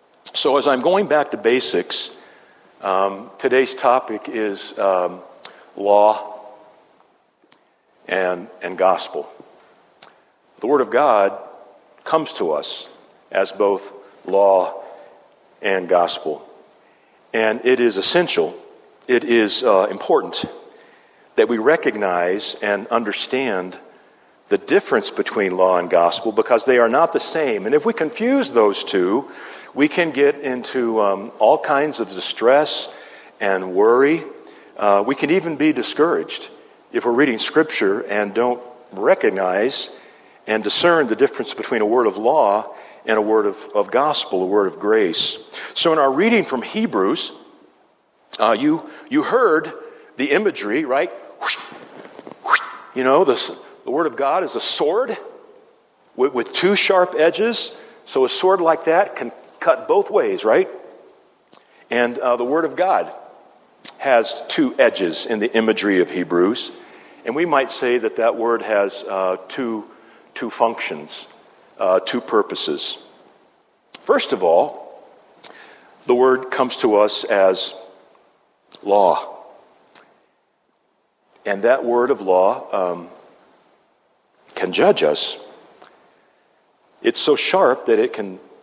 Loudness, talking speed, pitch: -18 LUFS, 135 wpm, 175 Hz